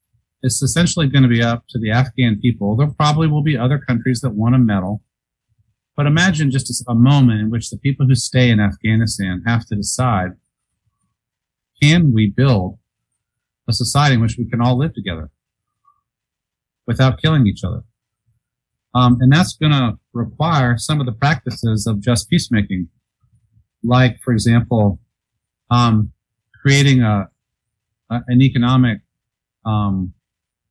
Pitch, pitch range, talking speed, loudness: 120 Hz, 110-130 Hz, 145 wpm, -16 LUFS